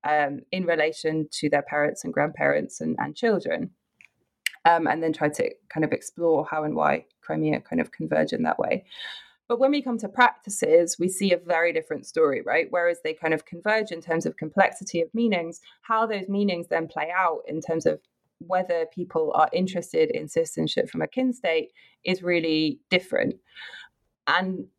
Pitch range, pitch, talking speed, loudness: 155-225 Hz, 175 Hz, 185 wpm, -25 LUFS